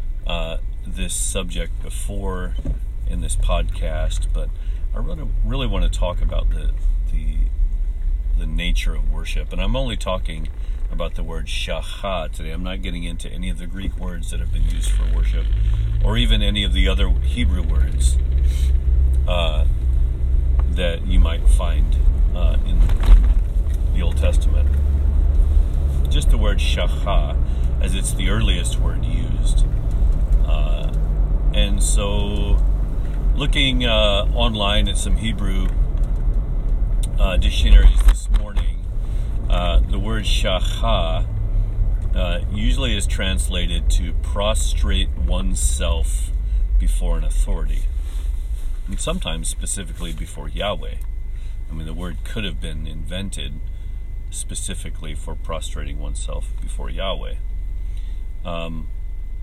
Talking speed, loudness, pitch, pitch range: 120 wpm, -22 LUFS, 85 Hz, 70-95 Hz